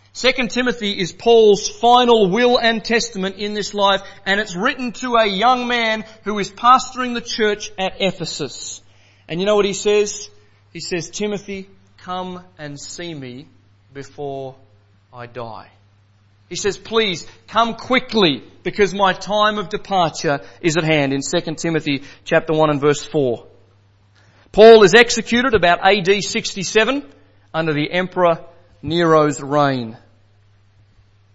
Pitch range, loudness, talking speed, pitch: 130-210 Hz, -17 LUFS, 140 wpm, 180 Hz